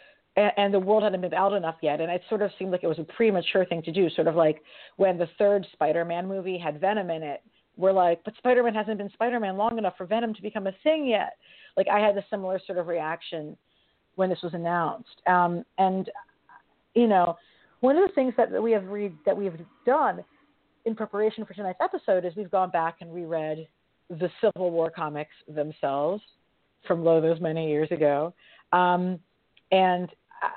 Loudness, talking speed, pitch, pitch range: -26 LUFS, 200 wpm, 185 Hz, 170-210 Hz